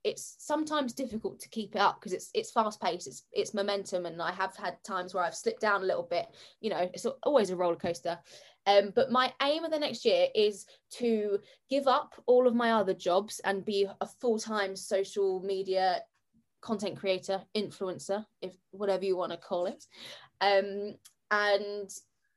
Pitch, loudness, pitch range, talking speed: 200 Hz, -31 LUFS, 190-235 Hz, 185 wpm